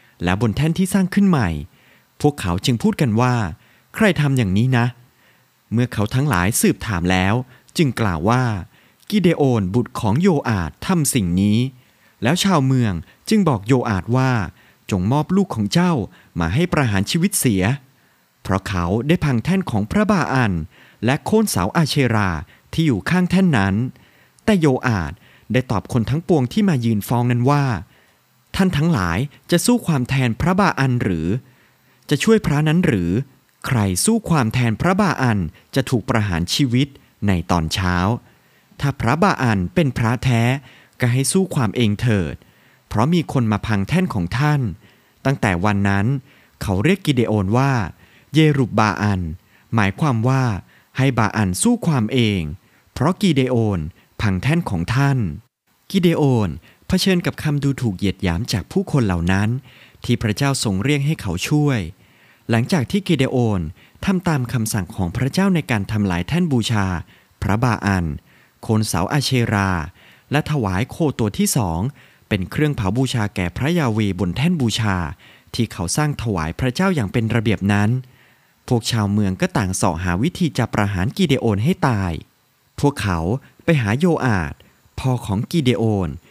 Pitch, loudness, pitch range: 120 Hz, -19 LUFS, 100-145 Hz